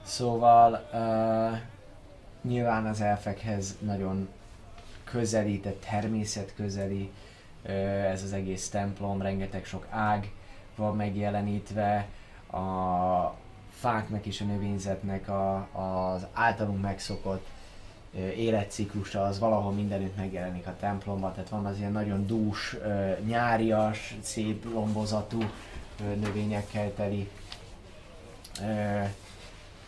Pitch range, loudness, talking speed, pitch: 95-105 Hz, -30 LUFS, 100 wpm, 100 Hz